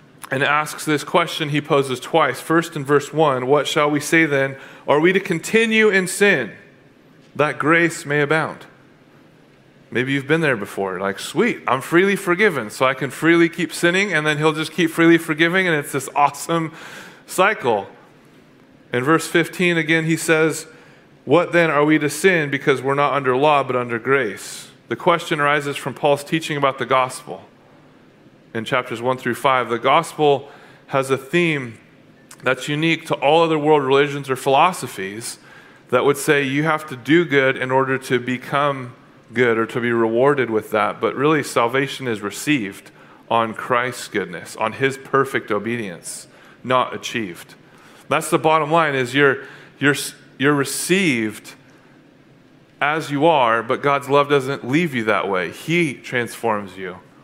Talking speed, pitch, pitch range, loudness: 165 wpm, 145 Hz, 130-160 Hz, -19 LUFS